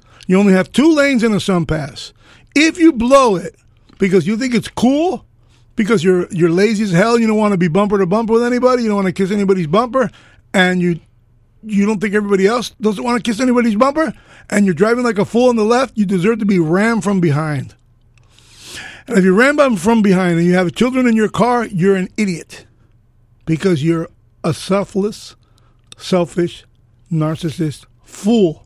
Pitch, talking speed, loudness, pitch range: 195 Hz, 195 wpm, -15 LUFS, 160-225 Hz